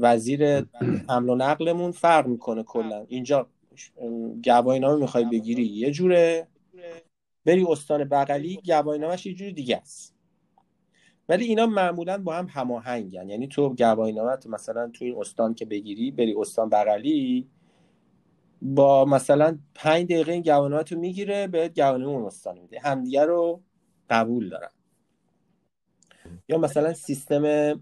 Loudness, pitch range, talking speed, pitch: -24 LUFS, 120-170 Hz, 130 wpm, 145 Hz